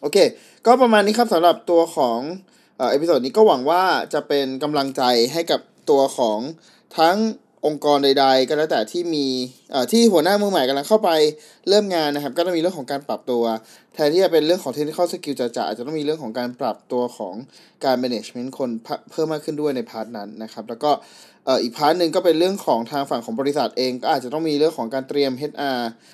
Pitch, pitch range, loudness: 150 Hz, 130-175 Hz, -20 LUFS